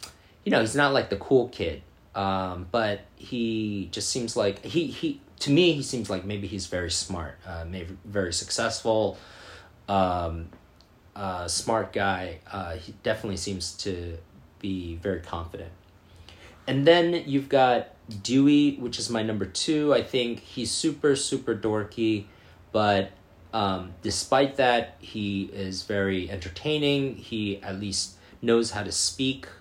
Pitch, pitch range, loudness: 100 Hz, 90-115 Hz, -26 LUFS